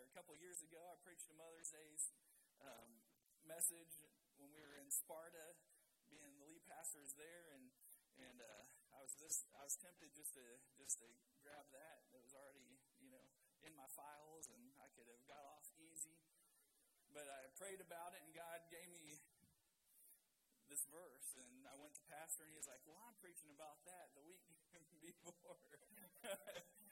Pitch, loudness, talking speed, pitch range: 160 Hz, -54 LUFS, 180 wpm, 145-170 Hz